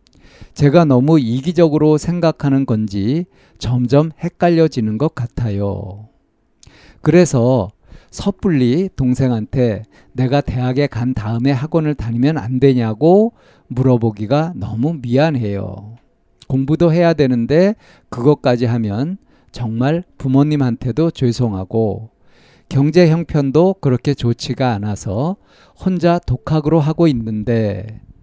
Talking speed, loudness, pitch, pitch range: 250 characters per minute, -16 LUFS, 130 Hz, 115-155 Hz